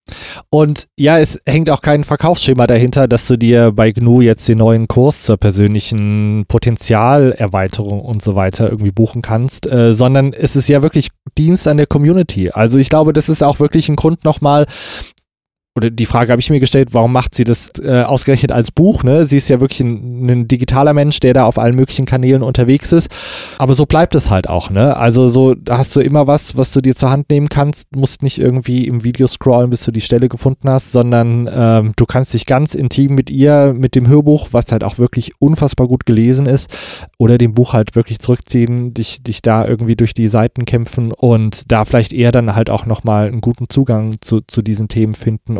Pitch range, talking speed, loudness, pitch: 115-140 Hz, 210 wpm, -12 LUFS, 125 Hz